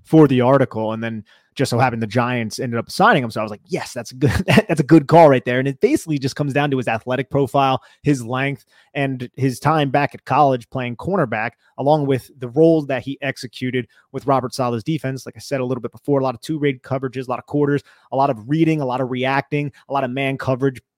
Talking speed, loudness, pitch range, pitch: 255 wpm, -19 LUFS, 125-145 Hz, 135 Hz